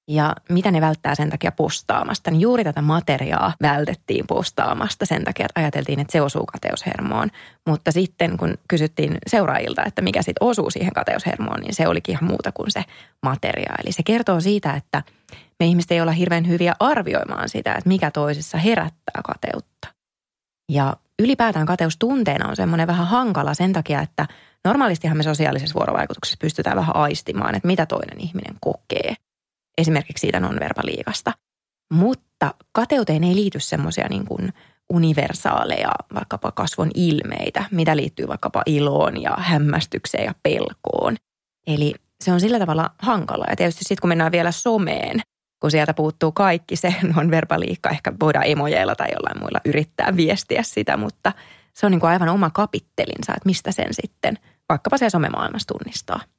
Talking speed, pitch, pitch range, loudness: 155 wpm, 170 Hz, 155-185 Hz, -21 LUFS